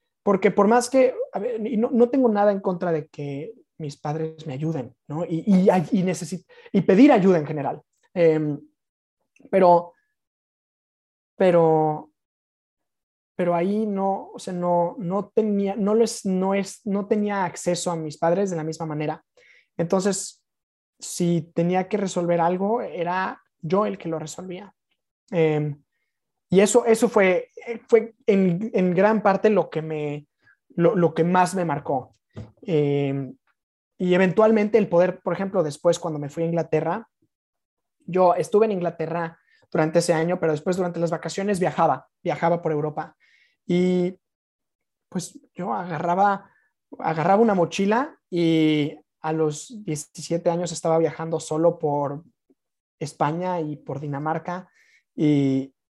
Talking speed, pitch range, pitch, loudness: 145 wpm, 160-200 Hz, 175 Hz, -22 LUFS